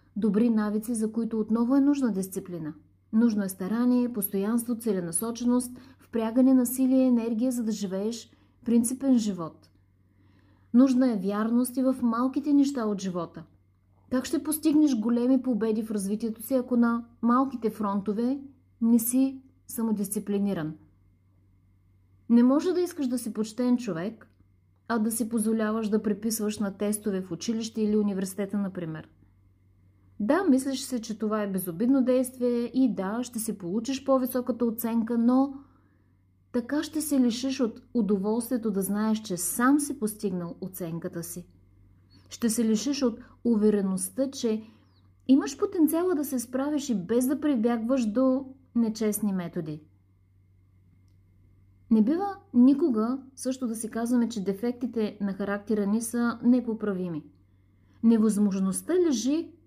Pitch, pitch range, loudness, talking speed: 225 Hz, 190-250 Hz, -27 LUFS, 135 wpm